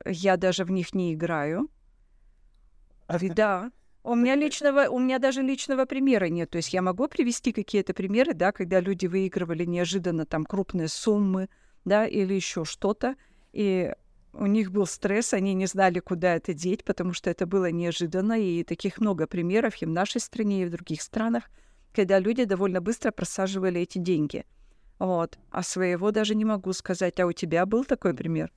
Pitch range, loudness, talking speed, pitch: 180-220 Hz, -26 LUFS, 175 wpm, 190 Hz